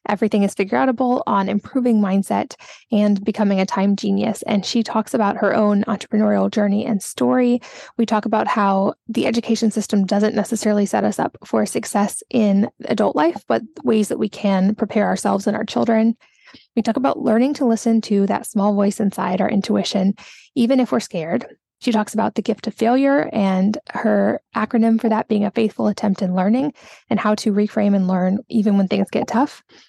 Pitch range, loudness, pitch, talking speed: 200-225 Hz, -19 LUFS, 215 Hz, 190 wpm